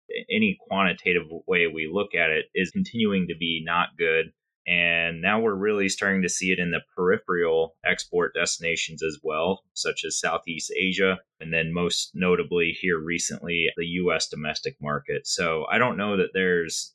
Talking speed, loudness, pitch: 170 wpm, -24 LUFS, 95 Hz